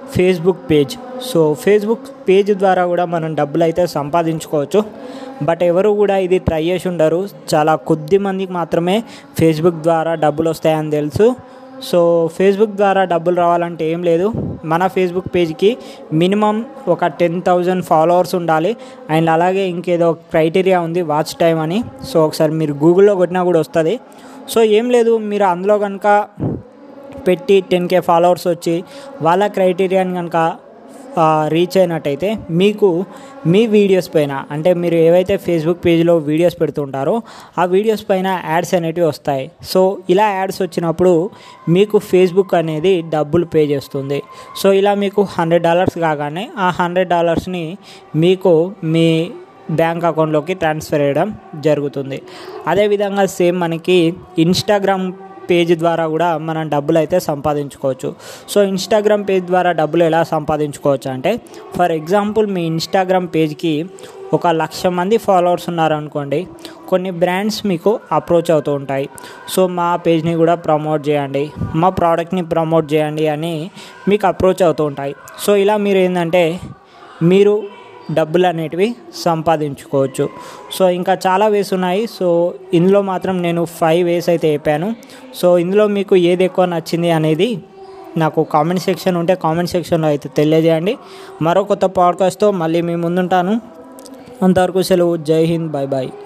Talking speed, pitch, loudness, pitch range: 135 wpm, 175 Hz, -15 LUFS, 160-195 Hz